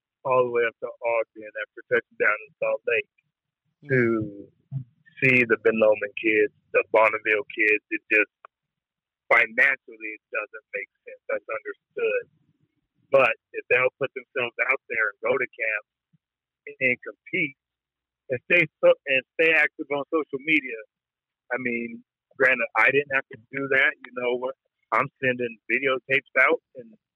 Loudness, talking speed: -23 LUFS, 155 wpm